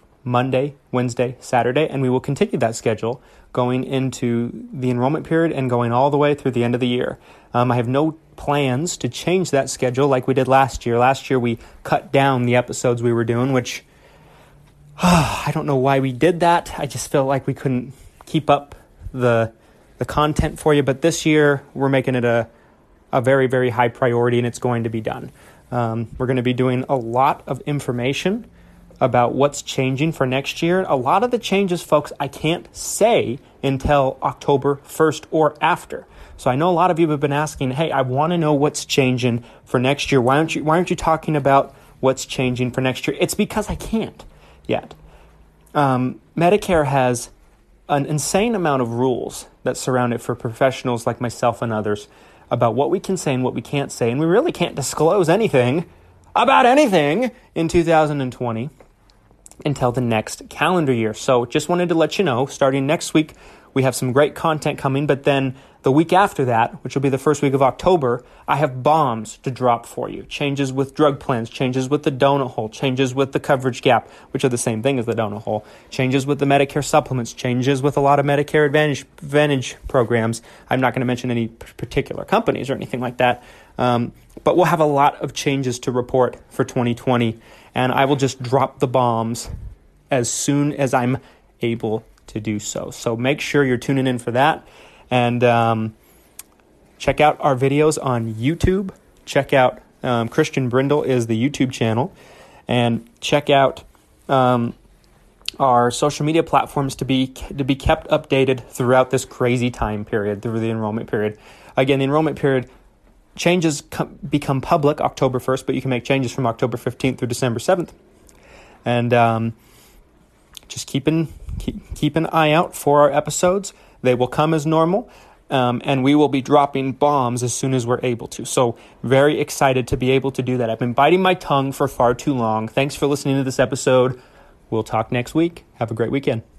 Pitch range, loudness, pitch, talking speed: 125-145 Hz, -19 LUFS, 135 Hz, 195 wpm